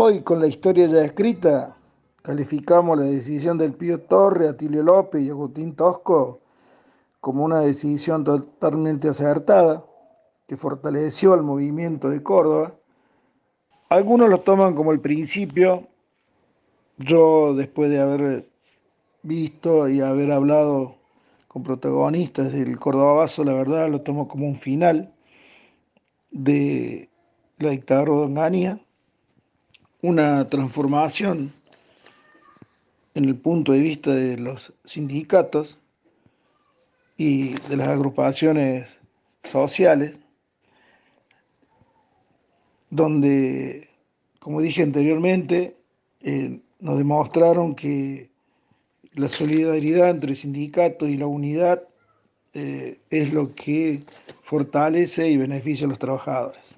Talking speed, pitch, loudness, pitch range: 105 wpm, 150 Hz, -20 LUFS, 140-165 Hz